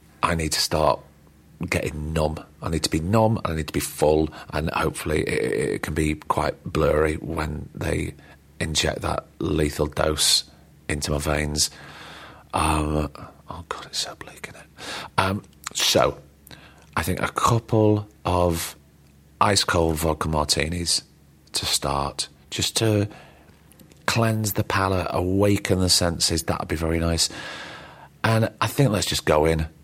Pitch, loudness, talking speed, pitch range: 80 Hz, -23 LUFS, 150 wpm, 75-90 Hz